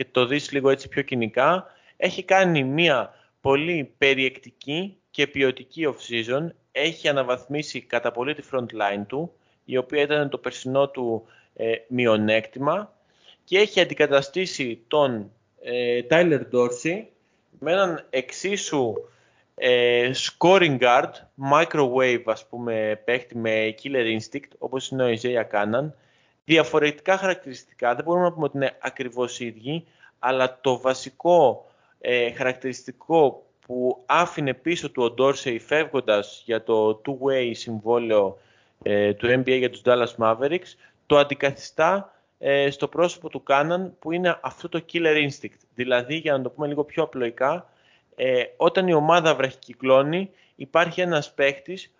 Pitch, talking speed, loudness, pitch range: 135 Hz, 135 wpm, -23 LUFS, 125-155 Hz